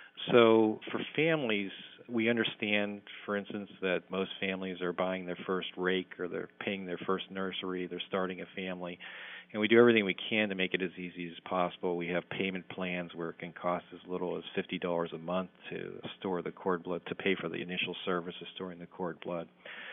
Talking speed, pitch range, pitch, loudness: 205 wpm, 90-100 Hz, 95 Hz, -33 LUFS